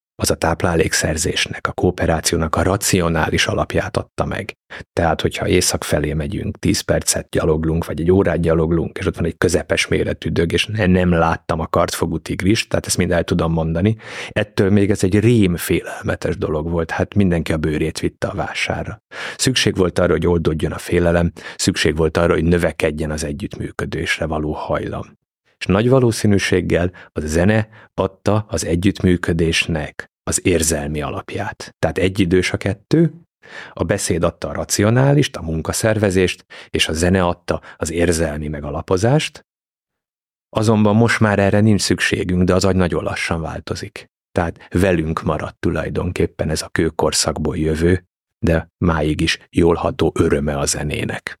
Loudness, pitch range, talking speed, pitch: -18 LUFS, 80-100 Hz, 150 wpm, 90 Hz